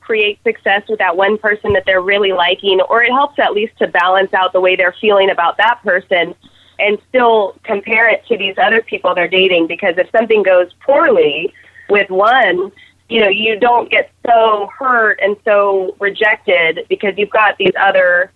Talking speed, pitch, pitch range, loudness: 185 wpm, 205 Hz, 190-235 Hz, -12 LUFS